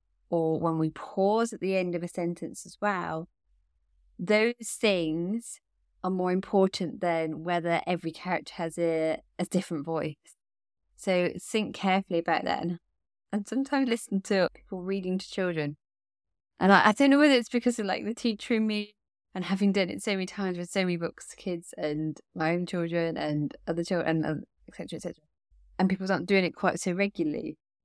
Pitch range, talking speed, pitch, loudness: 165-200 Hz, 180 wpm, 180 Hz, -29 LUFS